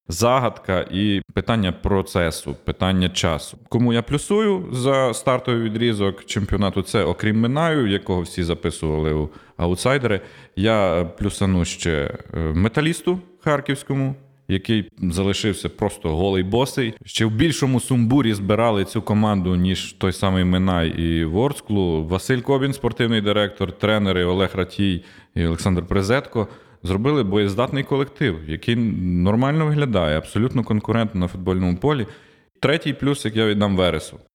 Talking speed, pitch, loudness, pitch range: 125 wpm, 105 Hz, -21 LUFS, 90-120 Hz